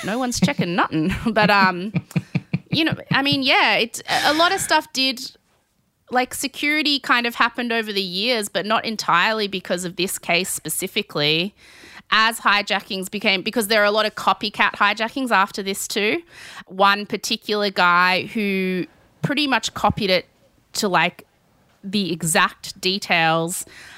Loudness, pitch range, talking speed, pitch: -20 LUFS, 180-230 Hz, 150 wpm, 205 Hz